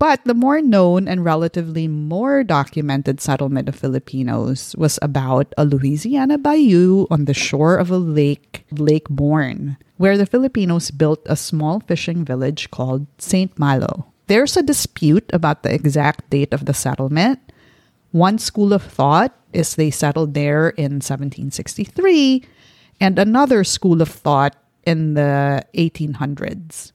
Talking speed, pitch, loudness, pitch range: 140 wpm, 155 Hz, -17 LUFS, 140-190 Hz